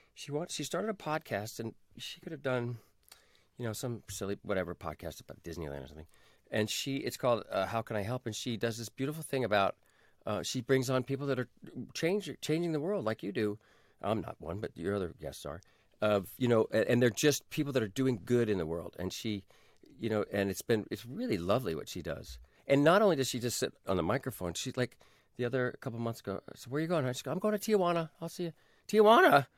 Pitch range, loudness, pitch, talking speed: 100-140 Hz, -33 LUFS, 120 Hz, 240 wpm